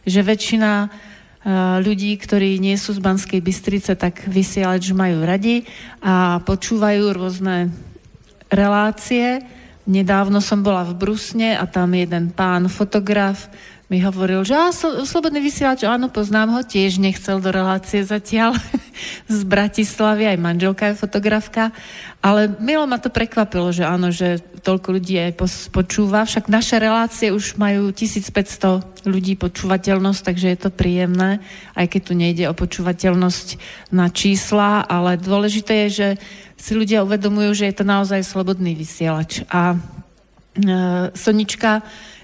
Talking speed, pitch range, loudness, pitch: 140 wpm, 185-215 Hz, -18 LUFS, 200 Hz